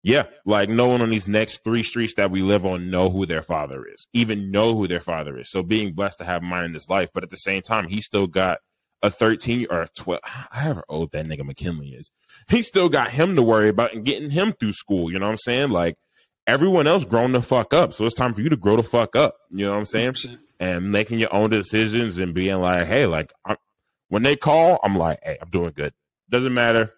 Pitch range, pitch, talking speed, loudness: 90-120 Hz, 105 Hz, 255 wpm, -21 LUFS